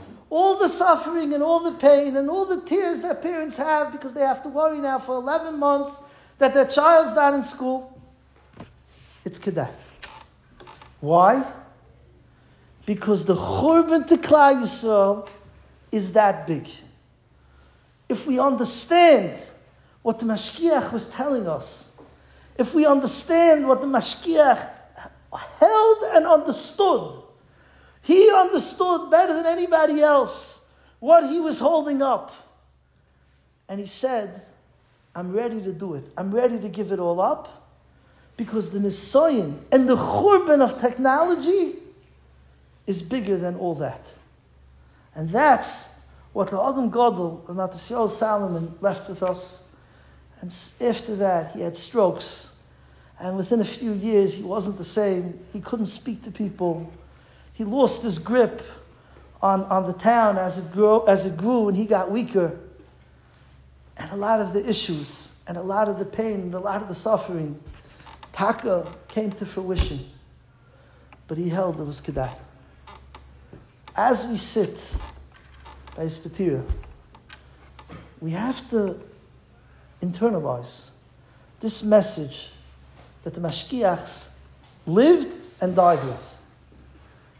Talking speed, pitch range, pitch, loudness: 130 wpm, 165-275 Hz, 210 Hz, -21 LUFS